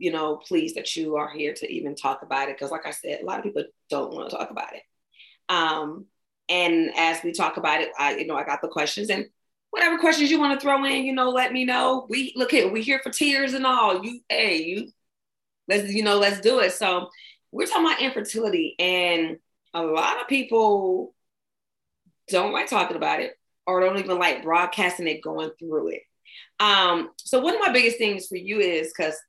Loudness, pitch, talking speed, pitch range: -23 LUFS, 200 Hz, 215 wpm, 165-260 Hz